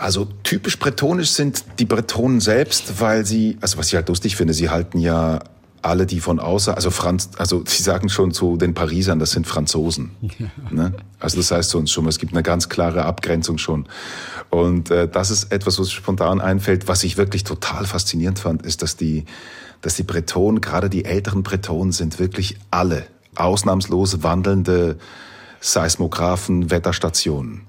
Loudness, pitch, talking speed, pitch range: -19 LUFS, 90 Hz, 175 wpm, 85-100 Hz